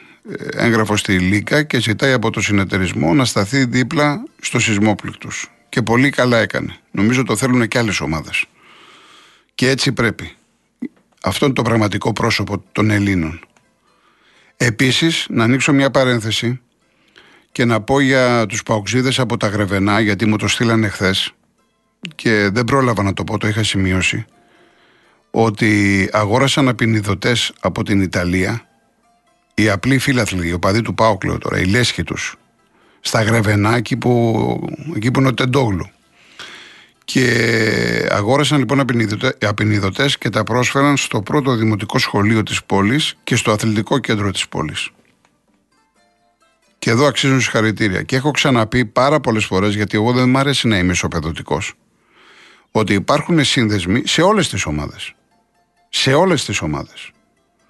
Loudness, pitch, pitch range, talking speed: -16 LUFS, 115 Hz, 105-130 Hz, 140 wpm